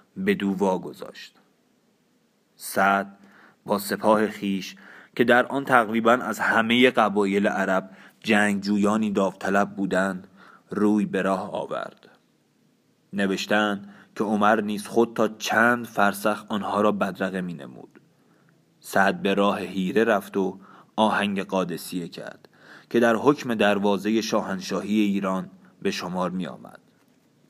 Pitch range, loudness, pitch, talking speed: 100-115 Hz, -23 LUFS, 105 Hz, 120 wpm